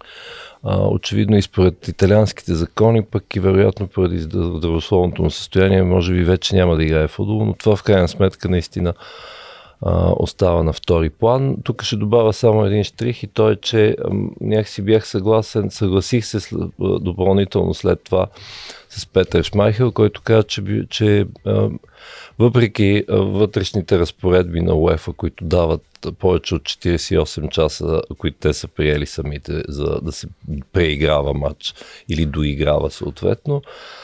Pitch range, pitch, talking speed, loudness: 85-110 Hz, 95 Hz, 140 wpm, -18 LUFS